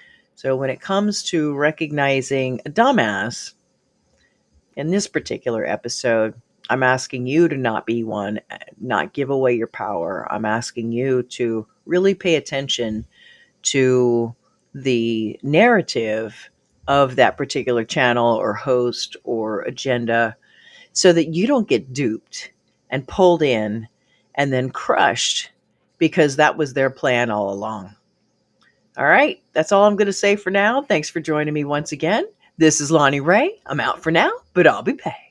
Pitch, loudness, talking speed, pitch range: 135 Hz, -19 LUFS, 150 wpm, 115-160 Hz